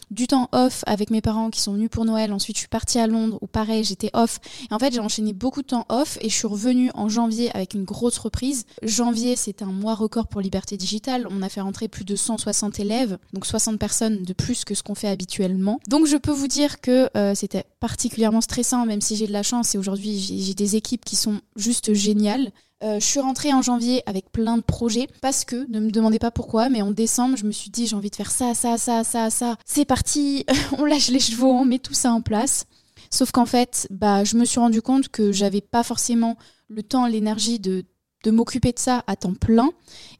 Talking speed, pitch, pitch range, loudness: 240 wpm, 225 Hz, 210-245 Hz, -22 LUFS